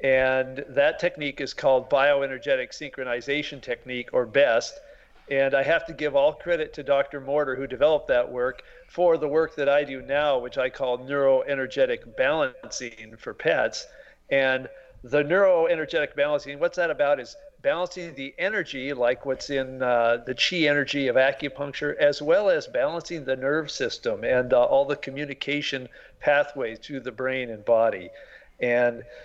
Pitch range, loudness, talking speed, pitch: 130-165 Hz, -25 LUFS, 160 wpm, 140 Hz